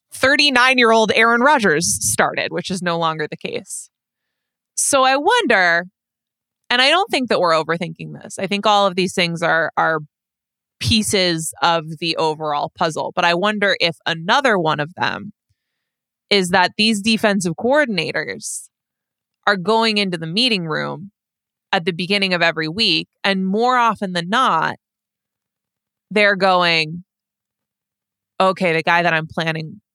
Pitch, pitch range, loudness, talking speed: 190 Hz, 165-220 Hz, -17 LUFS, 145 wpm